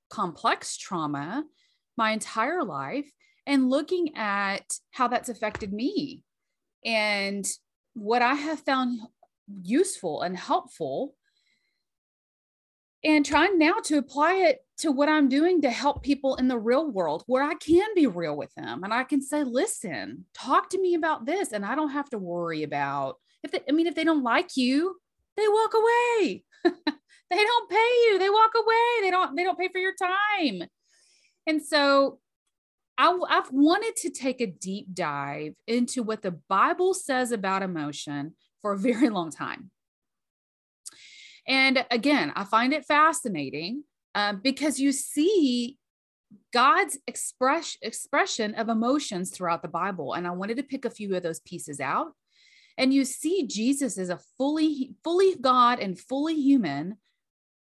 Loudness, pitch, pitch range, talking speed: -26 LUFS, 275 Hz, 220-330 Hz, 160 wpm